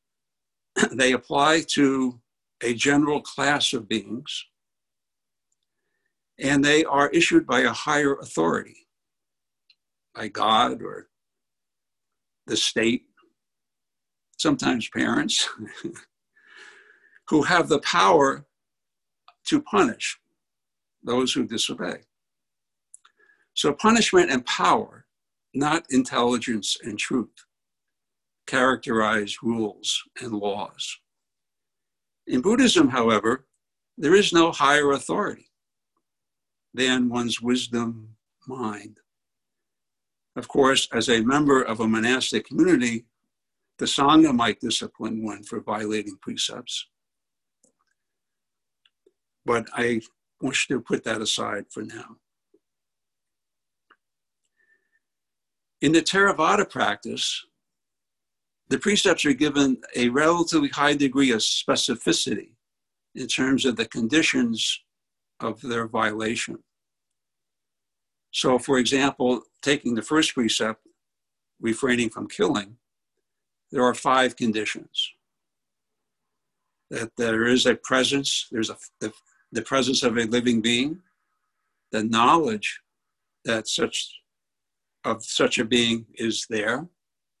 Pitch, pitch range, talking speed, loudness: 130 Hz, 115-150 Hz, 95 wpm, -23 LUFS